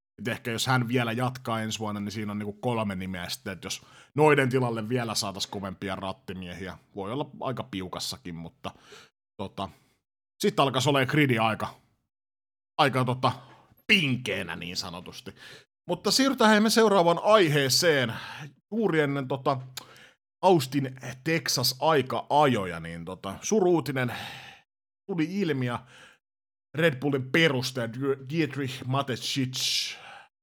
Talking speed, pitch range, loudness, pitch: 120 wpm, 105-145 Hz, -26 LUFS, 130 Hz